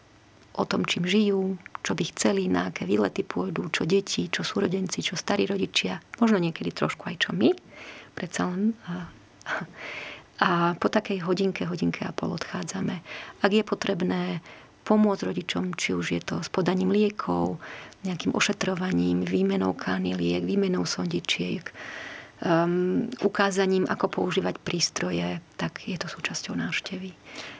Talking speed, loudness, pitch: 135 wpm, -27 LUFS, 180 Hz